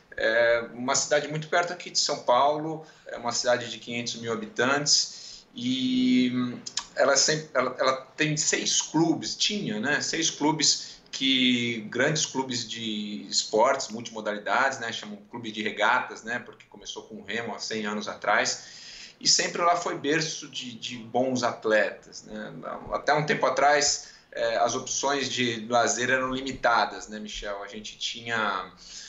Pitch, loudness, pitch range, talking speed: 130 Hz, -26 LUFS, 115-155 Hz, 155 wpm